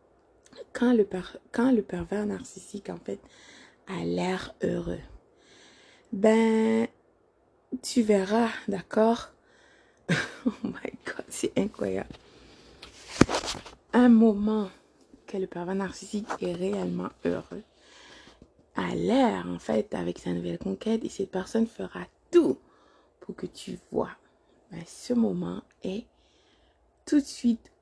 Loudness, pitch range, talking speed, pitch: -28 LUFS, 185-240 Hz, 115 wpm, 215 Hz